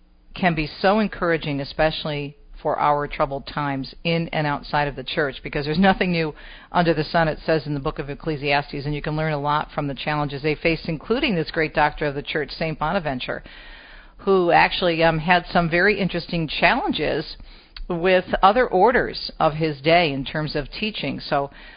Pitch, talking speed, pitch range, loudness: 155 Hz, 185 wpm, 145-175 Hz, -22 LUFS